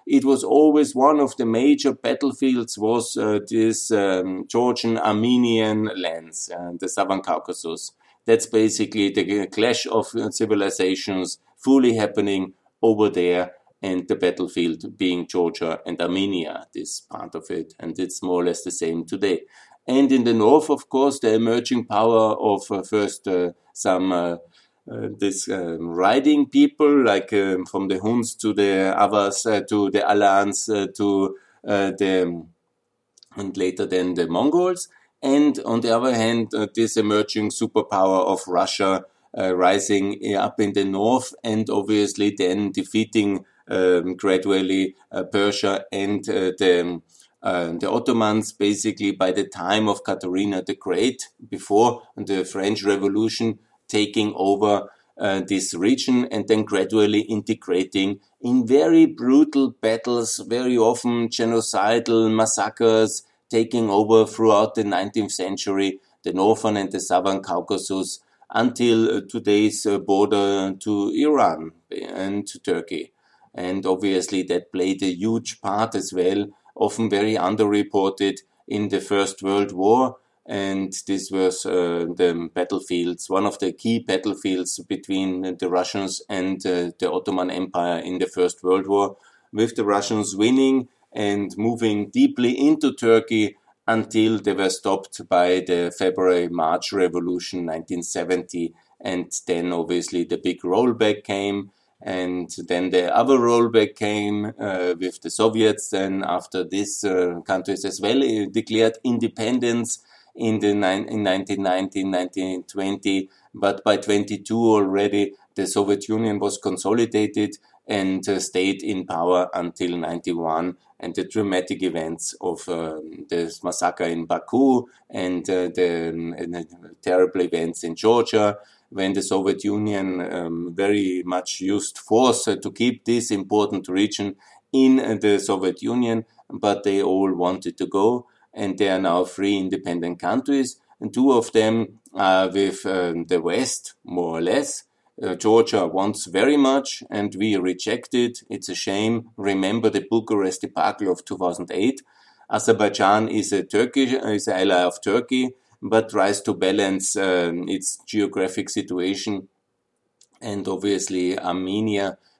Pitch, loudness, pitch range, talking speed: 100 Hz, -22 LUFS, 95-110 Hz, 140 wpm